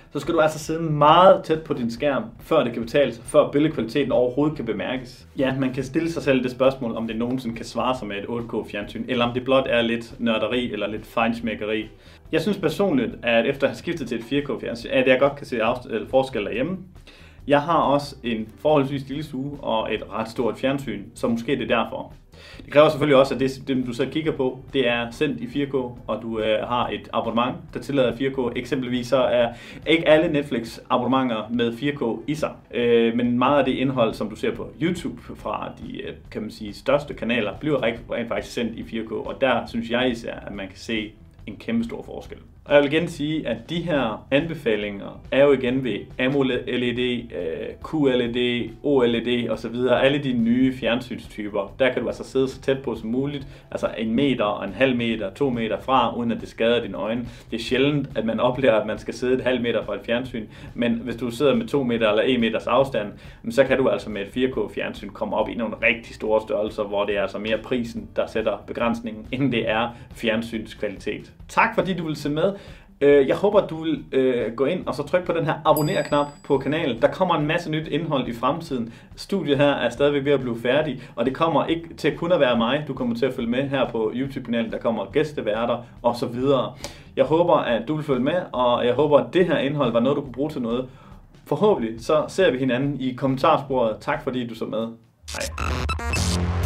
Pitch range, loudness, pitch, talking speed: 115-145 Hz, -23 LUFS, 130 Hz, 215 wpm